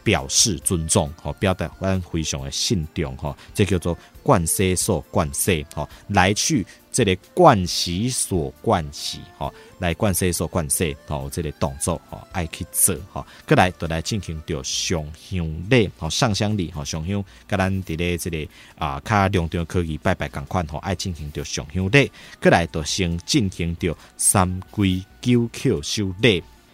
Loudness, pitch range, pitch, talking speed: -22 LUFS, 80-100 Hz, 90 Hz, 235 characters per minute